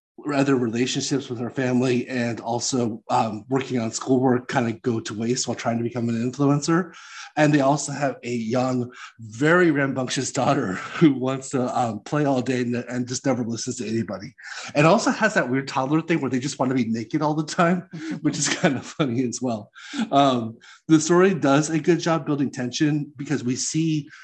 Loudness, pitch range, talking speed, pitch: -23 LUFS, 125-150 Hz, 200 wpm, 130 Hz